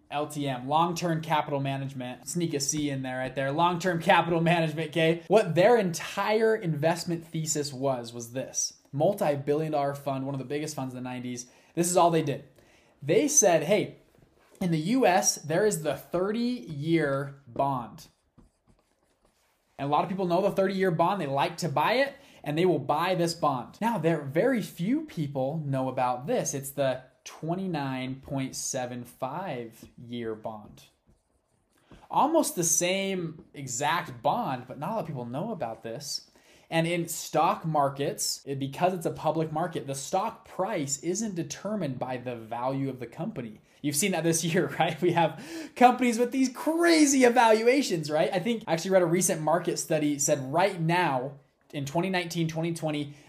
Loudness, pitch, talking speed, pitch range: -27 LUFS, 160 Hz, 165 wpm, 140-180 Hz